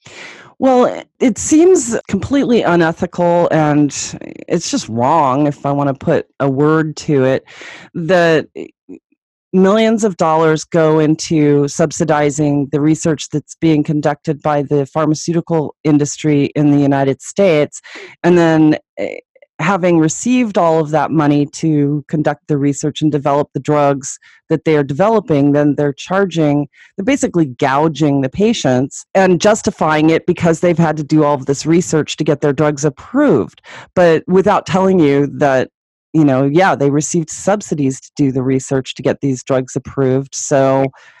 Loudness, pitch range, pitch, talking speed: -14 LUFS, 145-175 Hz, 155 Hz, 150 wpm